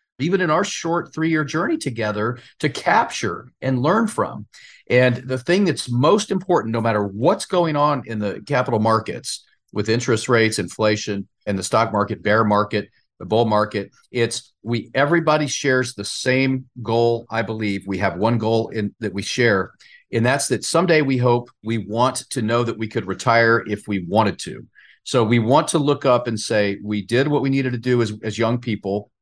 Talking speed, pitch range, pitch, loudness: 195 wpm, 105-135 Hz, 115 Hz, -20 LUFS